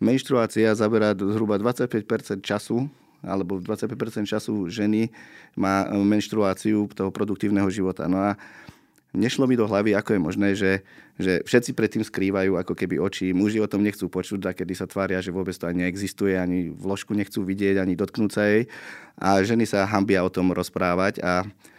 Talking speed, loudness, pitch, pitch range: 170 wpm, -24 LUFS, 100 Hz, 95-105 Hz